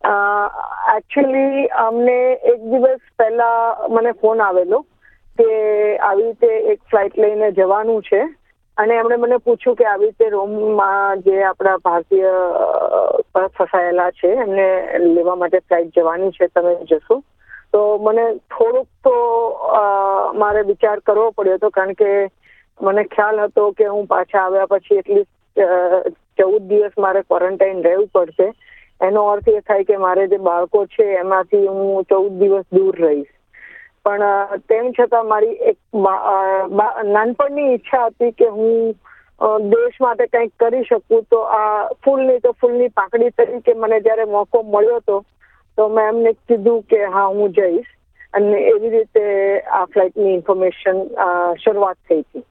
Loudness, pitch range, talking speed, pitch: -16 LUFS, 195-245 Hz, 140 wpm, 210 Hz